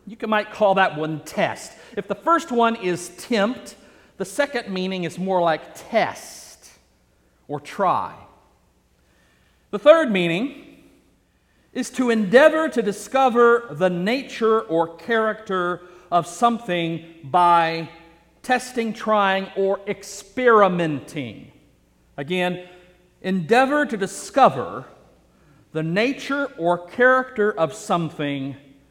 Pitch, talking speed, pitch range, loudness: 190 Hz, 105 wpm, 165-230 Hz, -21 LUFS